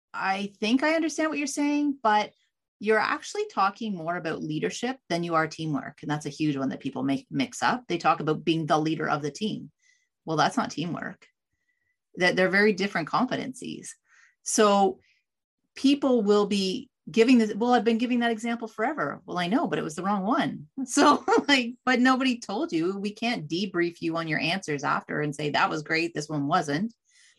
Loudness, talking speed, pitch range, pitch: -26 LUFS, 195 wpm, 165-260 Hz, 215 Hz